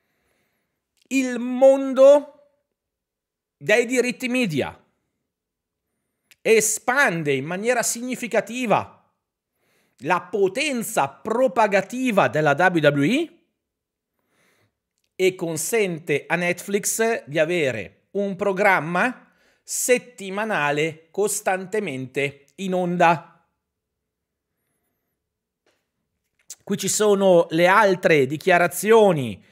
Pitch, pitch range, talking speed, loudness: 200 Hz, 170-245 Hz, 65 wpm, -20 LUFS